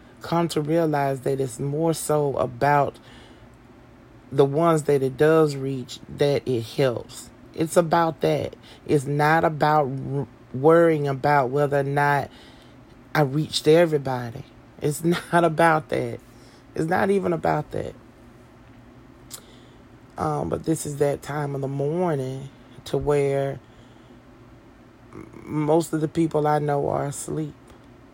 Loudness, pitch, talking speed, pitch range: -23 LUFS, 140 Hz, 130 wpm, 125-155 Hz